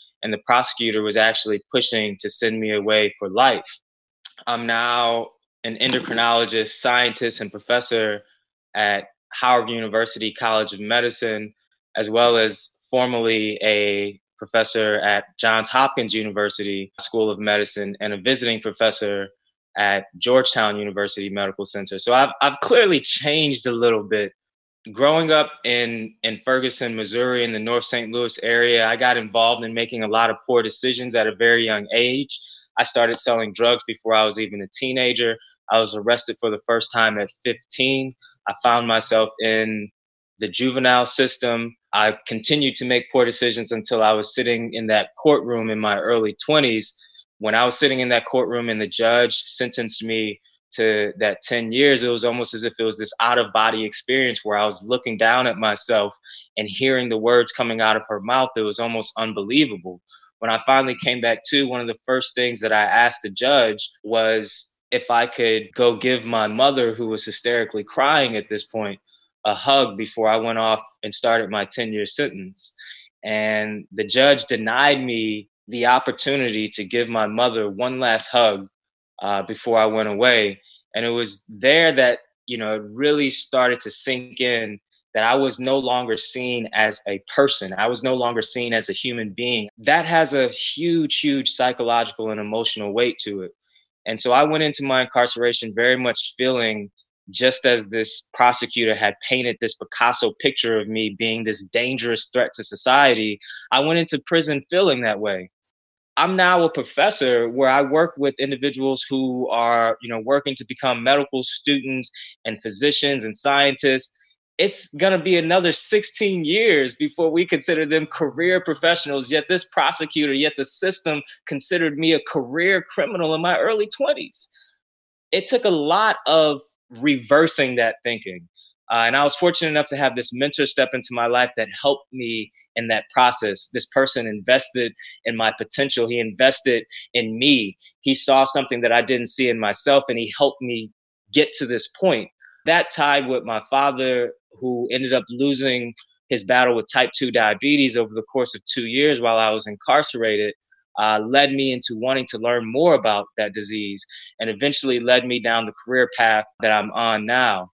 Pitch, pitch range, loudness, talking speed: 120 Hz, 110-135 Hz, -20 LUFS, 175 wpm